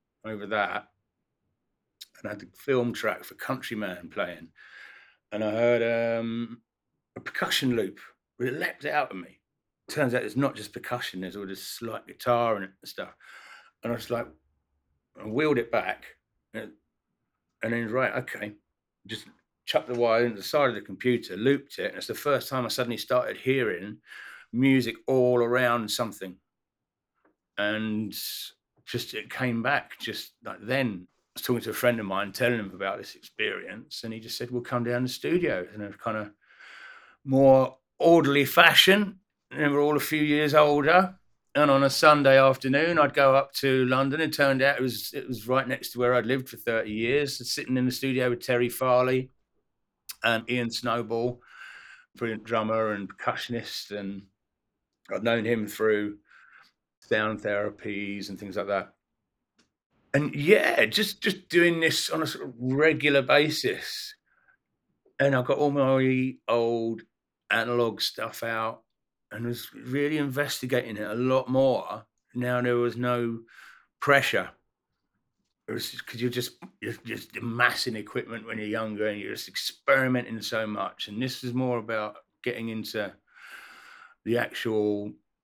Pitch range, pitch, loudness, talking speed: 110-135 Hz, 120 Hz, -26 LUFS, 165 wpm